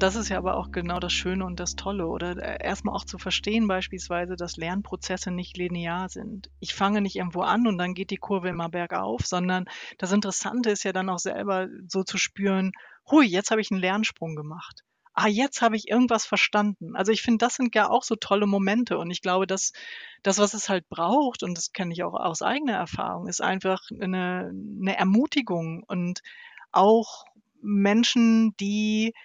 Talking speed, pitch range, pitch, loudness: 195 wpm, 185-220 Hz, 195 Hz, -25 LUFS